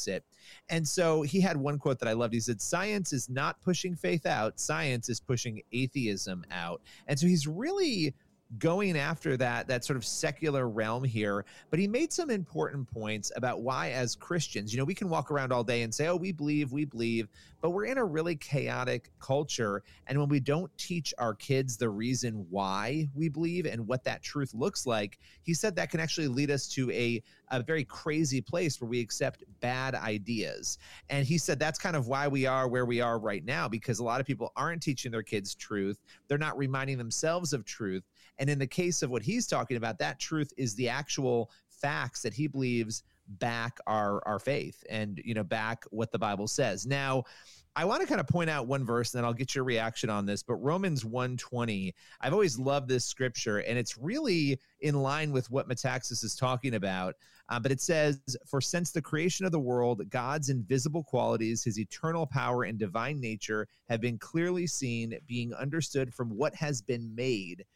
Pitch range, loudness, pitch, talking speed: 115-150 Hz, -32 LUFS, 130 Hz, 205 wpm